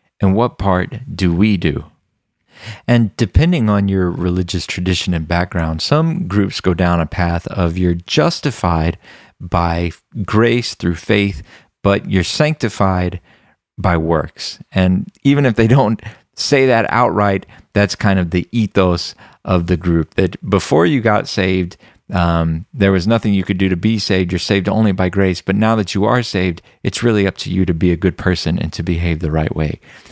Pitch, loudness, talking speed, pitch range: 95 Hz, -16 LUFS, 180 wpm, 90-110 Hz